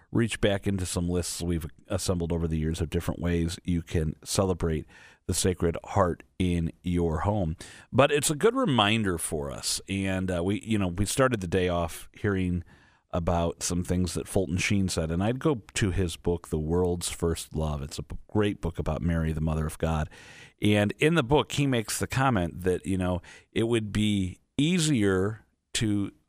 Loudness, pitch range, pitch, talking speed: -28 LUFS, 85-105 Hz, 90 Hz, 190 wpm